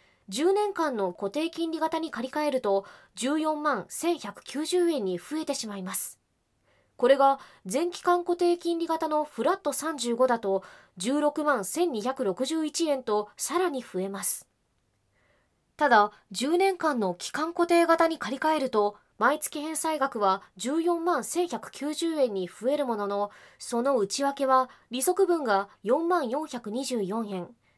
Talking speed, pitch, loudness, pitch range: 210 characters per minute, 280 Hz, -27 LUFS, 215-325 Hz